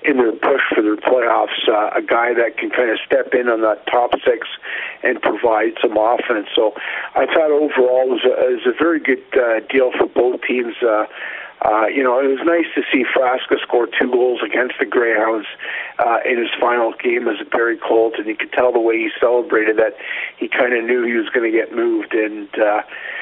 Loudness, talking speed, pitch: -17 LUFS, 220 wpm, 150 Hz